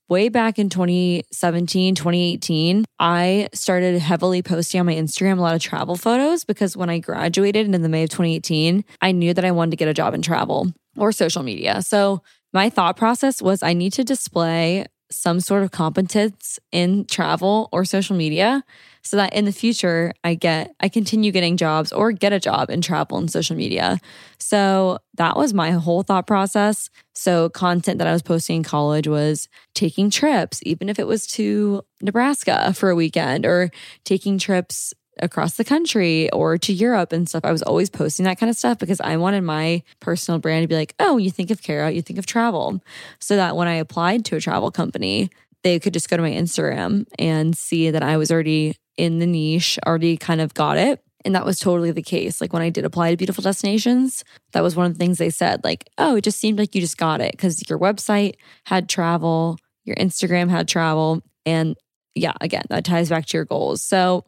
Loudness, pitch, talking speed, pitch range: -20 LUFS, 180 Hz, 210 wpm, 165-200 Hz